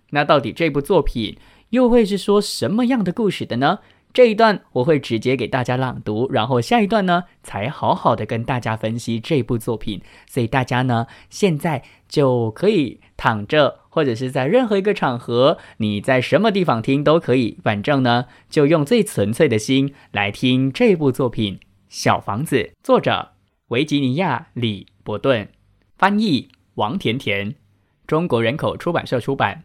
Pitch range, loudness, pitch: 115-170 Hz, -19 LUFS, 130 Hz